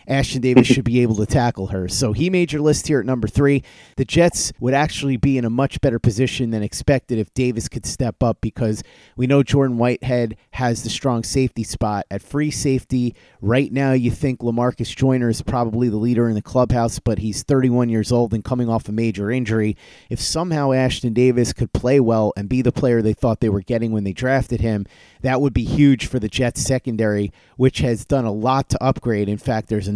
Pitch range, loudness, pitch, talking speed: 110-130 Hz, -19 LUFS, 120 Hz, 220 wpm